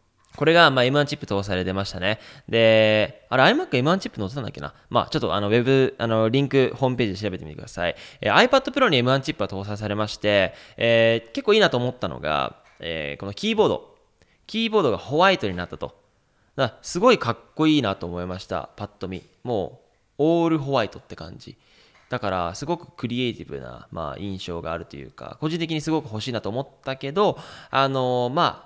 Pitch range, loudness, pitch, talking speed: 100-150 Hz, -22 LUFS, 120 Hz, 435 characters per minute